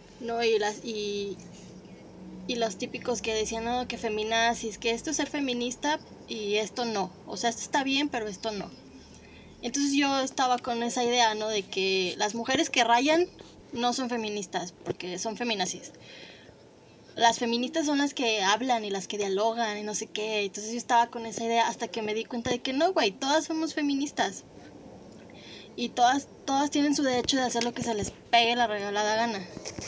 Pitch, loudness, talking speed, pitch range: 235 Hz, -28 LUFS, 190 wpm, 210-250 Hz